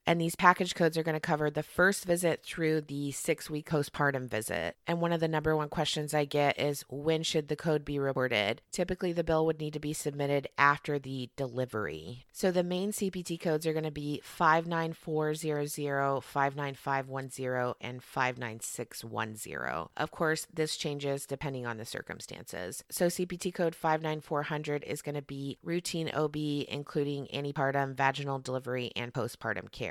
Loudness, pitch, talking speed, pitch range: -32 LUFS, 150 Hz, 165 wpm, 135-160 Hz